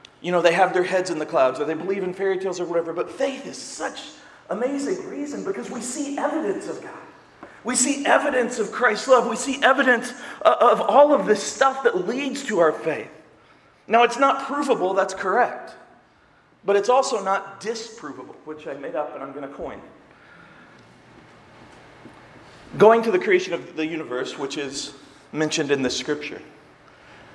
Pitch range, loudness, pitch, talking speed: 175-270 Hz, -22 LUFS, 225 Hz, 180 wpm